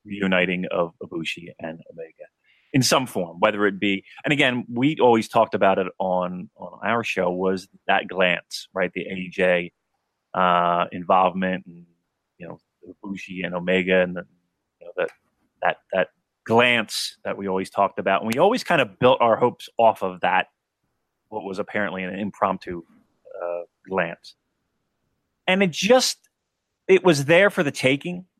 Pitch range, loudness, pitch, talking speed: 90-125 Hz, -22 LUFS, 95 Hz, 160 wpm